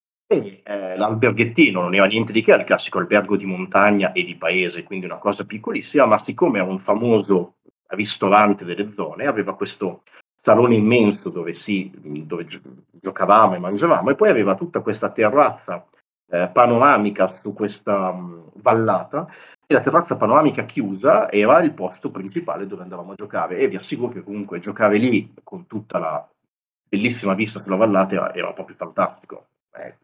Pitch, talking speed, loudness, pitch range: 100 Hz, 165 wpm, -19 LUFS, 95-105 Hz